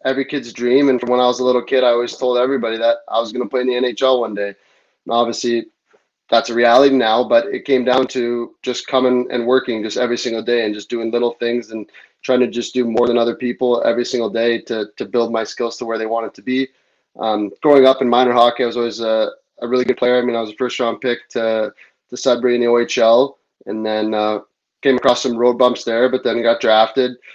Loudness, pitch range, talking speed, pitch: -17 LUFS, 115-125 Hz, 250 wpm, 120 Hz